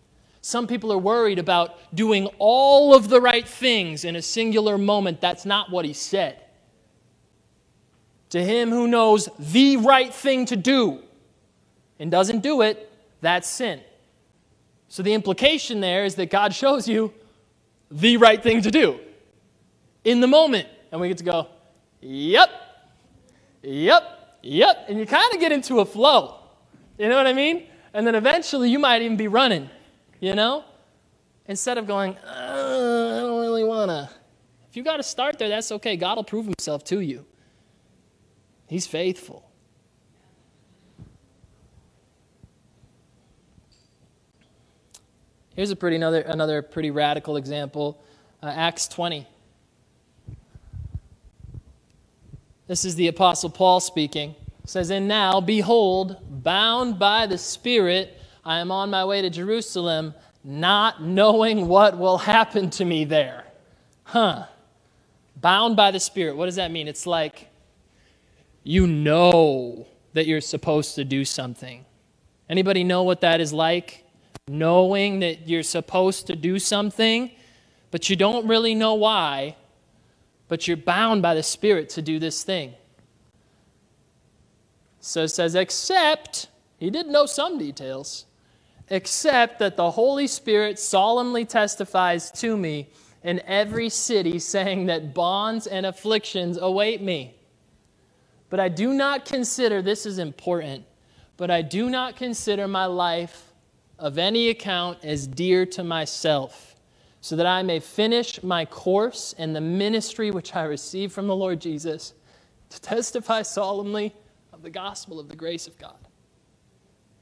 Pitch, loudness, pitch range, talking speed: 190 Hz, -21 LUFS, 165-225 Hz, 140 wpm